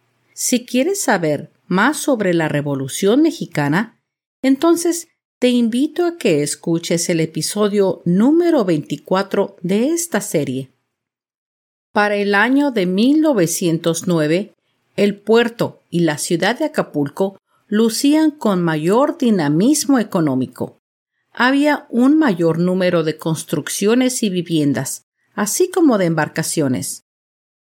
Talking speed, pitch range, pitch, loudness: 110 wpm, 160-255 Hz, 195 Hz, -17 LUFS